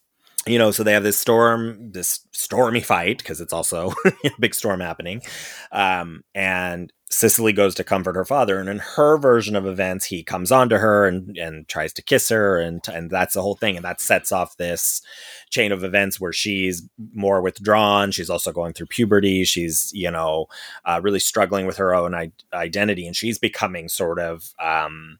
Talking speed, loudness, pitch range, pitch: 195 wpm, -20 LUFS, 90-105 Hz, 95 Hz